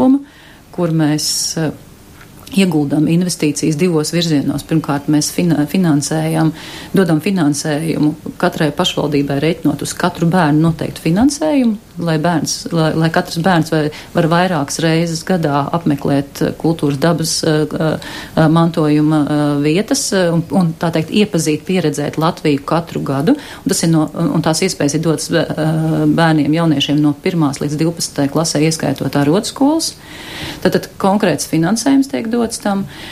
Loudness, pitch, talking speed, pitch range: -15 LUFS, 160 Hz, 130 wpm, 150-175 Hz